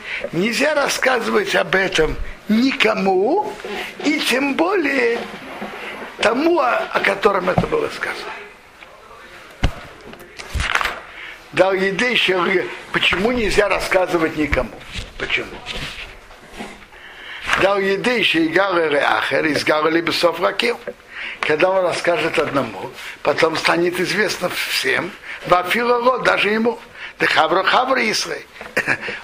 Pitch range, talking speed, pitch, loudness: 180-260 Hz, 75 wpm, 205 Hz, -18 LUFS